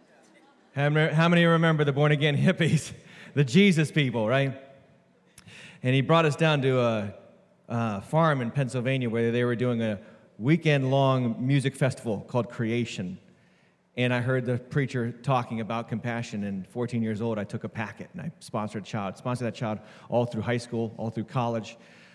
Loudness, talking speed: -26 LUFS, 170 wpm